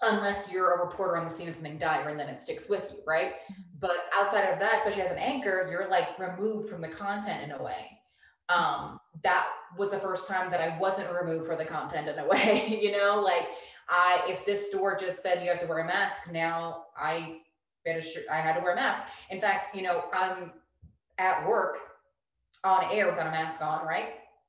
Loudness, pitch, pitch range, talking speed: -29 LUFS, 185 Hz, 165-200 Hz, 215 wpm